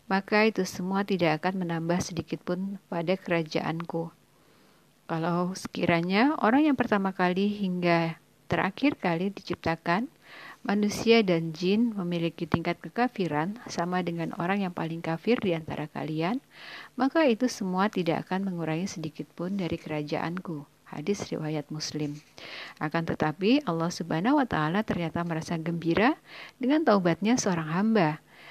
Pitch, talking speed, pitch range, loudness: 175 Hz, 130 wpm, 165-205 Hz, -28 LUFS